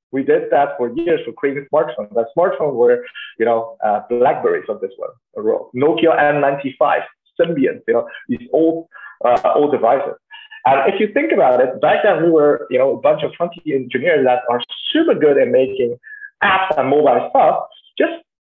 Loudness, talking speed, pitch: -16 LUFS, 180 wpm, 185 Hz